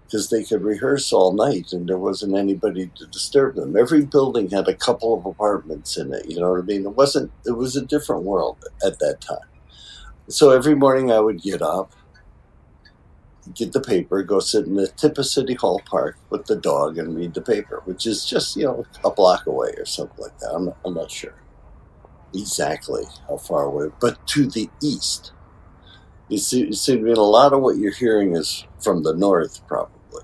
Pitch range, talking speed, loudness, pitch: 100-145 Hz, 205 wpm, -20 LUFS, 125 Hz